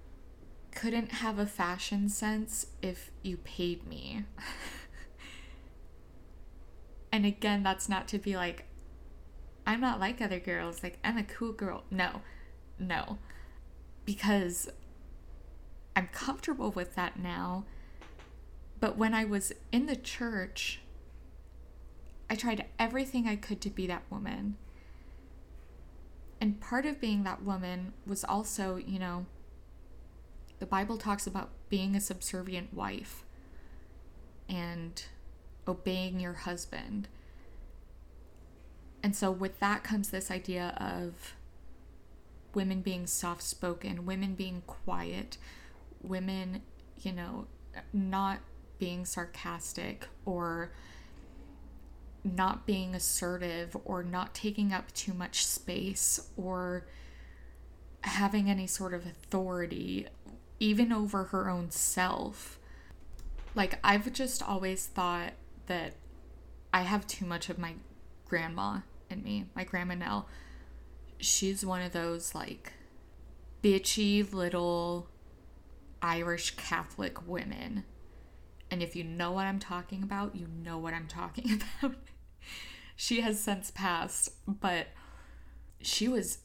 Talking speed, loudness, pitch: 115 wpm, -34 LUFS, 180 Hz